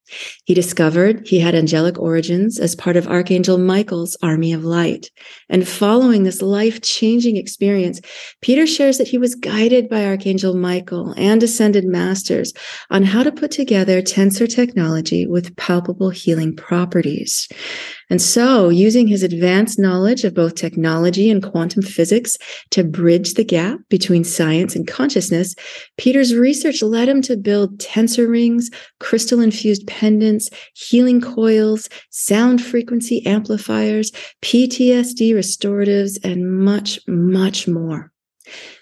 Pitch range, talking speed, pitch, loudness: 180-235 Hz, 130 wpm, 200 Hz, -16 LUFS